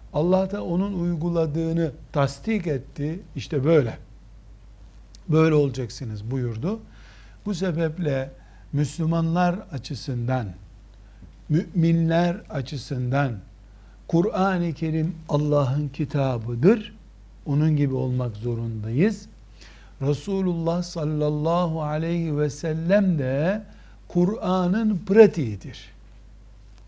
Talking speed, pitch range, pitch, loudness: 75 wpm, 120-170 Hz, 150 Hz, -24 LUFS